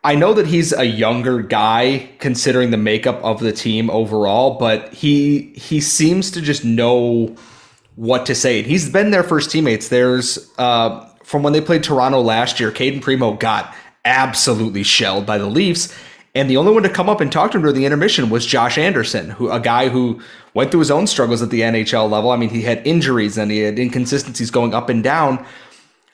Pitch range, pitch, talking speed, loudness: 115-145 Hz, 125 Hz, 205 wpm, -16 LUFS